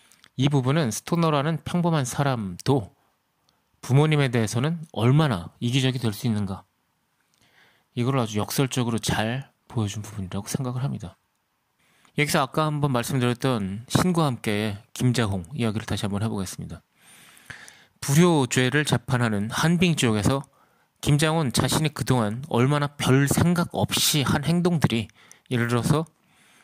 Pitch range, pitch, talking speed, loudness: 115-150 Hz, 130 Hz, 295 characters per minute, -24 LUFS